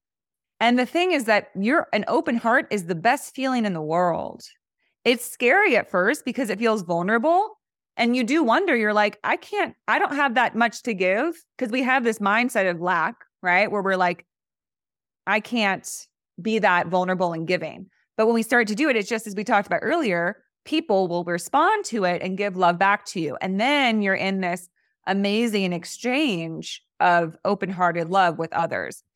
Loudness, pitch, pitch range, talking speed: -22 LUFS, 210 Hz, 180-245 Hz, 195 wpm